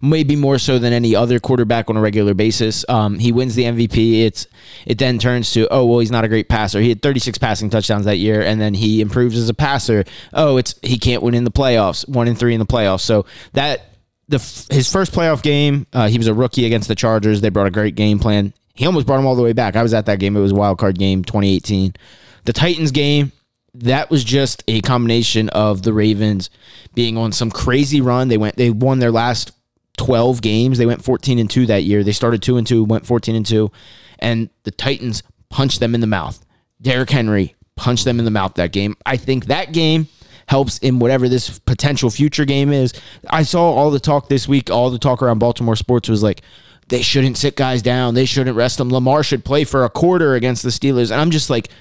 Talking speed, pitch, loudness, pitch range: 235 wpm, 120 Hz, -16 LUFS, 110-130 Hz